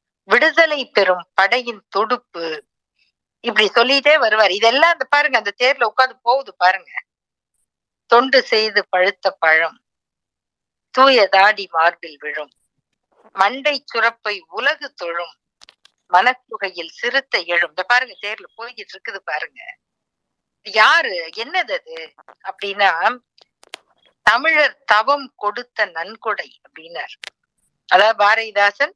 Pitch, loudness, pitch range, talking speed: 225 Hz, -16 LUFS, 195-265 Hz, 95 wpm